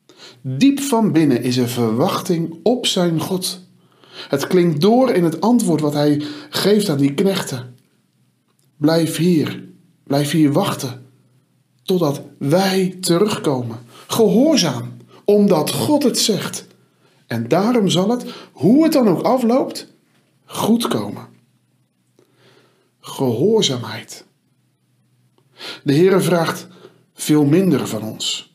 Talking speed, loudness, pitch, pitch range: 110 wpm, -17 LUFS, 165 Hz, 130-200 Hz